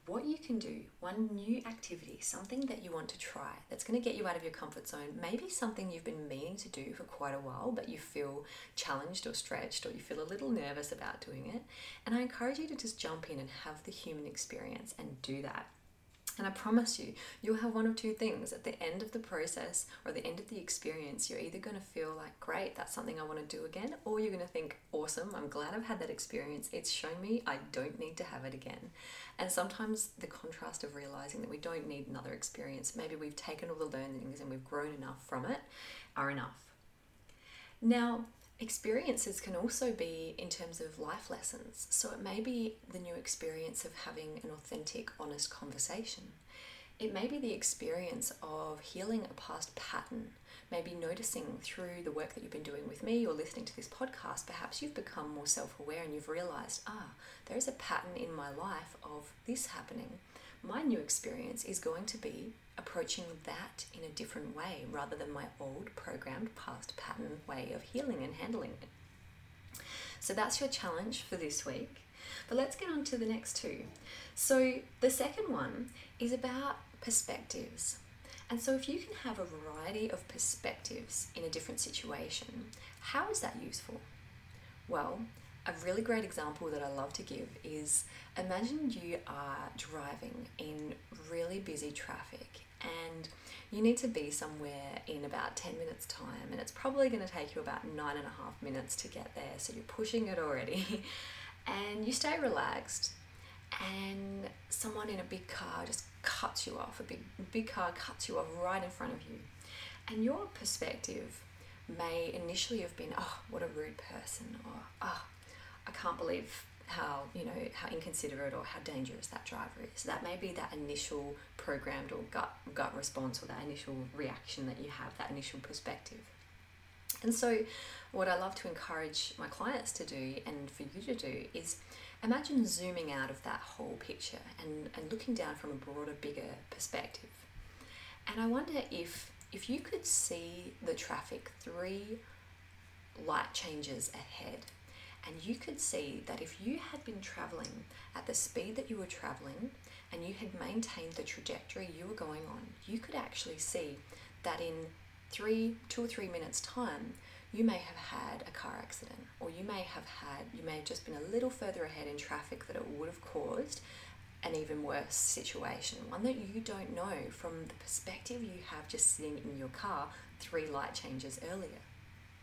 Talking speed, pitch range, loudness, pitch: 190 wpm, 145-240 Hz, -40 LUFS, 195 Hz